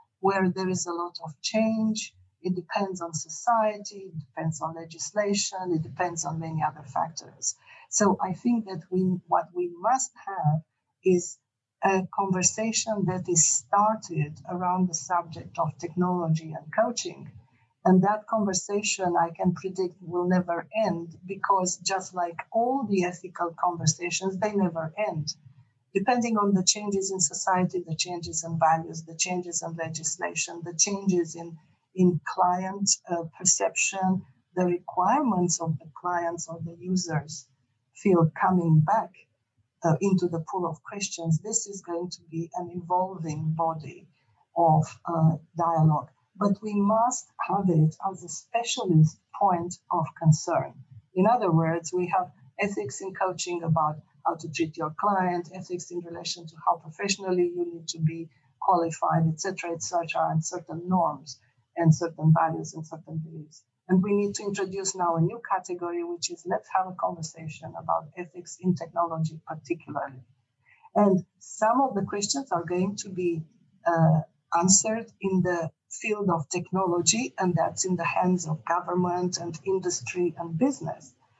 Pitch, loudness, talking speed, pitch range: 175 Hz, -27 LUFS, 155 wpm, 160-190 Hz